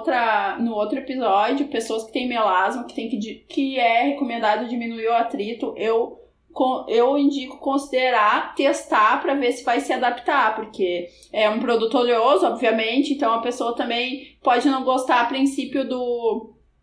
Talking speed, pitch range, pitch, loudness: 150 wpm, 225-270 Hz, 245 Hz, -21 LUFS